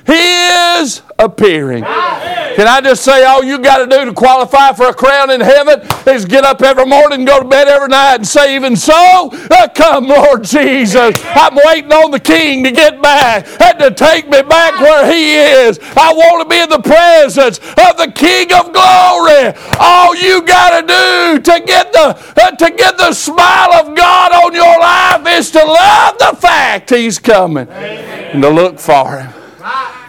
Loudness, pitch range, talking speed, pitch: -6 LUFS, 270-345 Hz, 185 wpm, 305 Hz